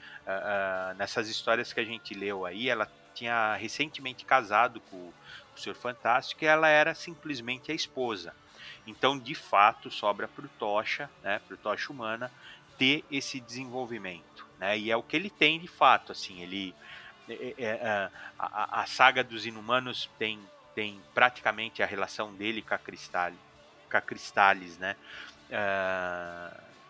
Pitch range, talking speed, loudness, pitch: 100-130 Hz, 145 wpm, -29 LUFS, 110 Hz